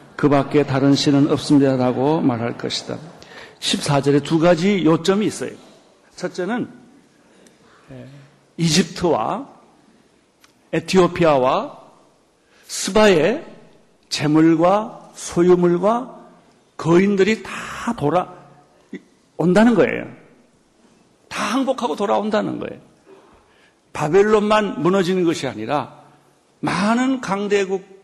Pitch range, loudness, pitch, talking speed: 150-205 Hz, -18 LUFS, 180 Hz, 205 characters per minute